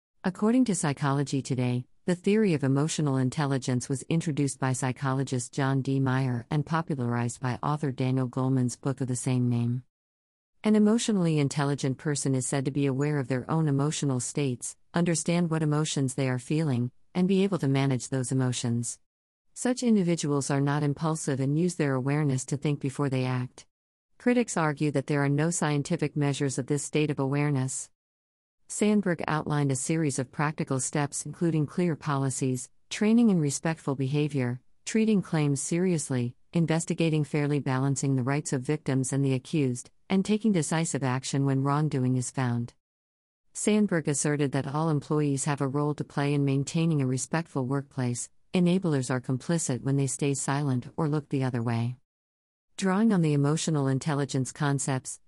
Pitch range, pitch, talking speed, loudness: 130-155 Hz, 140 Hz, 160 wpm, -28 LUFS